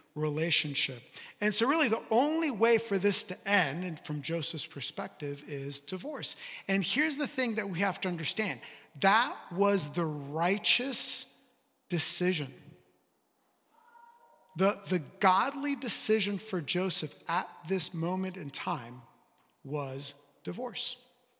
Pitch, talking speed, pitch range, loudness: 185 Hz, 125 wpm, 155-220 Hz, -30 LUFS